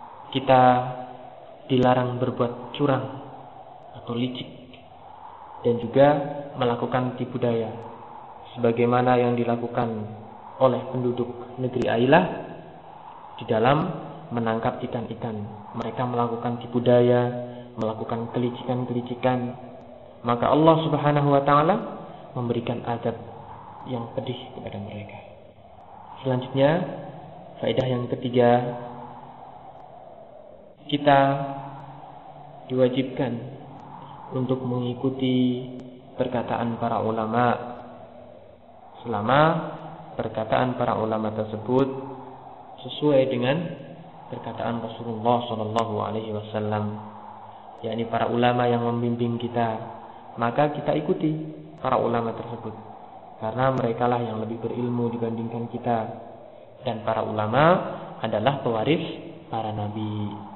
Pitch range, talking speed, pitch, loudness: 115-135 Hz, 85 wpm, 125 Hz, -24 LUFS